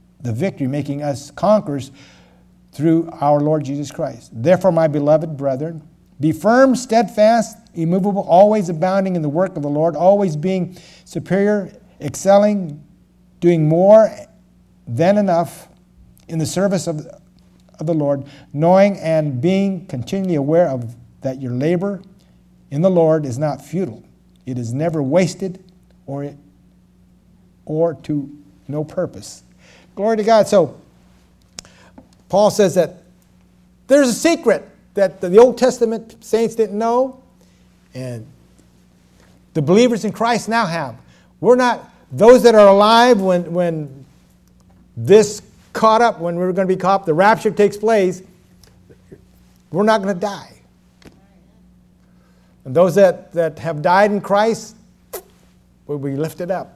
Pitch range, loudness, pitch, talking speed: 140-200 Hz, -16 LUFS, 170 Hz, 135 wpm